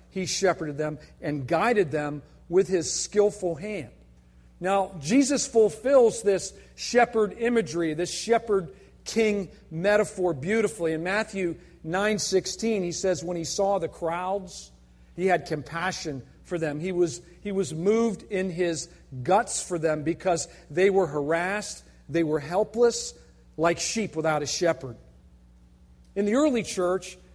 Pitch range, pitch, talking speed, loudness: 160-205 Hz, 180 Hz, 135 wpm, -26 LUFS